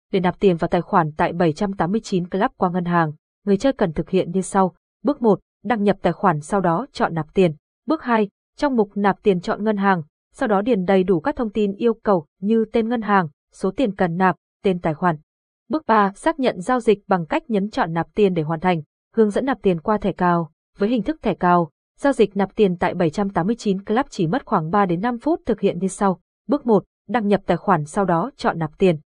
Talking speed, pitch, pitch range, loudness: 240 wpm, 195 Hz, 180-220 Hz, -21 LUFS